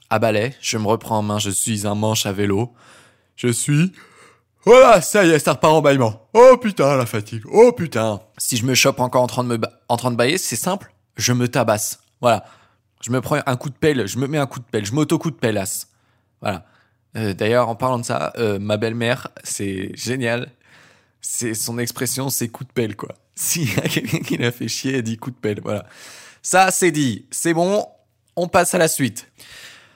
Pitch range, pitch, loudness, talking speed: 110-140 Hz, 120 Hz, -19 LUFS, 225 wpm